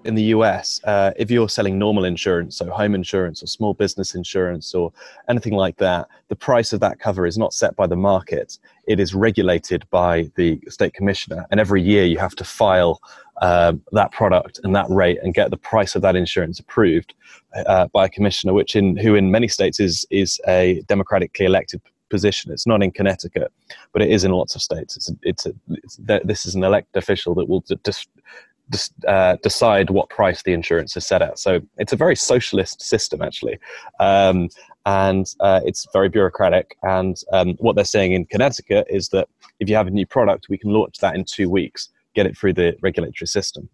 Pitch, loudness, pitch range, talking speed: 95 Hz, -19 LUFS, 90-105 Hz, 205 wpm